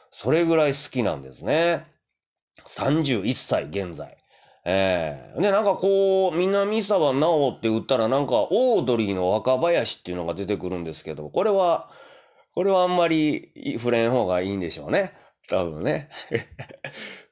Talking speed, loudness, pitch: 290 characters per minute, -23 LUFS, 130 Hz